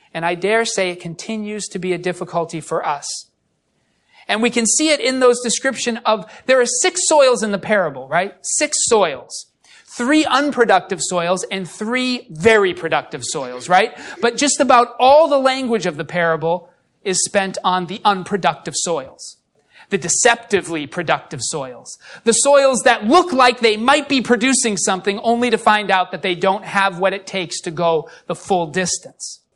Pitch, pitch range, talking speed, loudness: 205 Hz, 180-250 Hz, 175 wpm, -17 LUFS